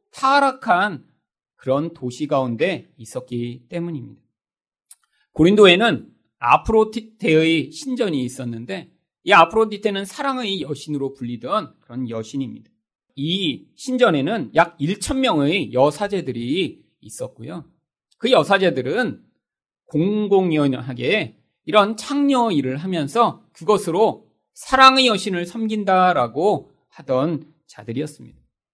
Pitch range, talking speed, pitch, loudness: 140-215 Hz, 255 characters per minute, 170 Hz, -19 LUFS